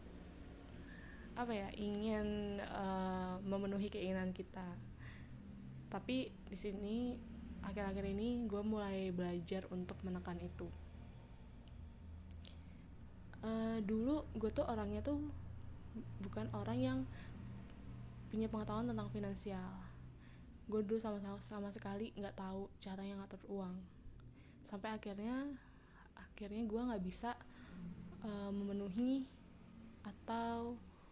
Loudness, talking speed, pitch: -43 LUFS, 100 wpm, 190 Hz